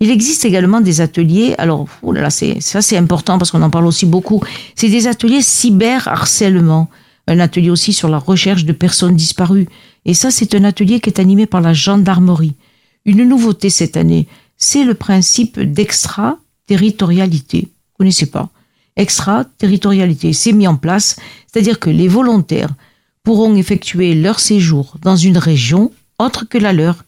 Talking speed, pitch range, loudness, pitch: 170 wpm, 165-215 Hz, -12 LUFS, 190 Hz